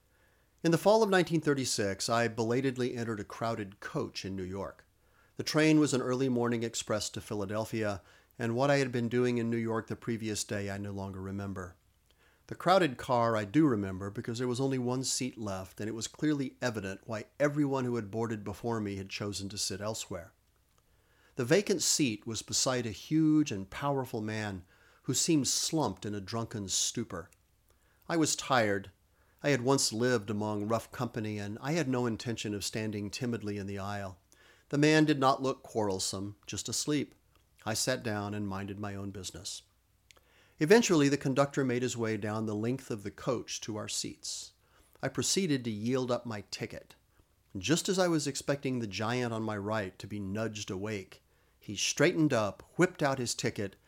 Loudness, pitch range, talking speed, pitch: -32 LUFS, 100-130 Hz, 185 wpm, 110 Hz